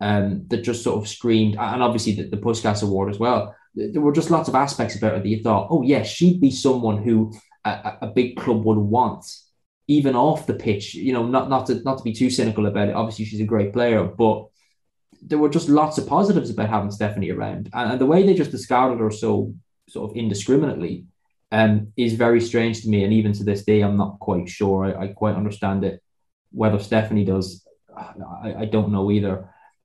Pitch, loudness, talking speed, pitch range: 110 Hz, -21 LUFS, 220 wpm, 105-125 Hz